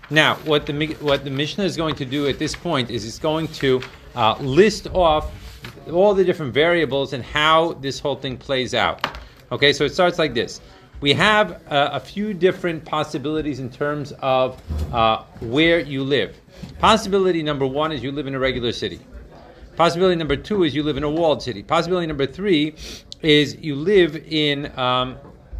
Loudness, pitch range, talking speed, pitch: -20 LUFS, 135-165 Hz, 185 wpm, 150 Hz